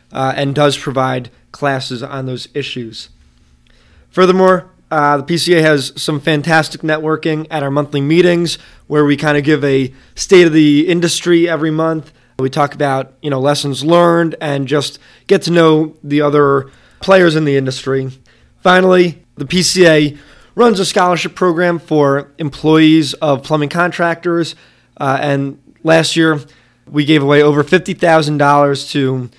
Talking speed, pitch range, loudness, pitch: 150 wpm, 140-165 Hz, -13 LUFS, 150 Hz